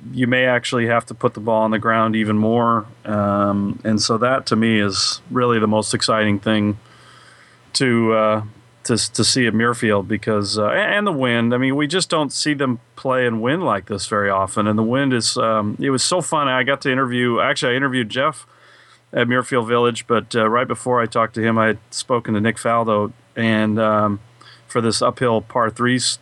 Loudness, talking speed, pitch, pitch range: -18 LUFS, 215 wpm, 115 Hz, 110-125 Hz